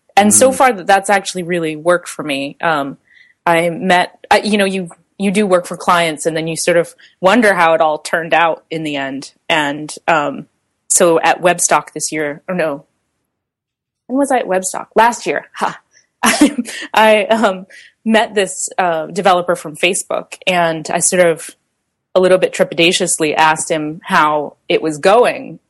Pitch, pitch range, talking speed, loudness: 180 Hz, 160-200 Hz, 175 wpm, -14 LUFS